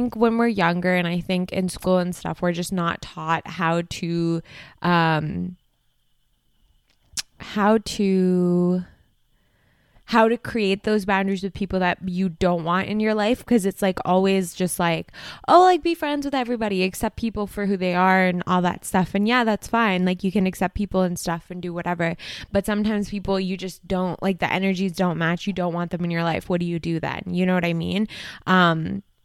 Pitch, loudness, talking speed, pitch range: 185 Hz, -22 LUFS, 200 wpm, 175-200 Hz